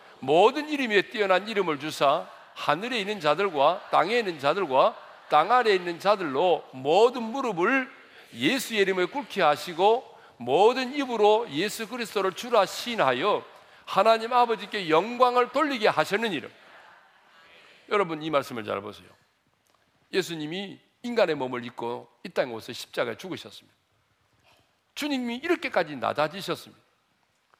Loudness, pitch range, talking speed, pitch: -25 LUFS, 165-245 Hz, 305 characters per minute, 210 Hz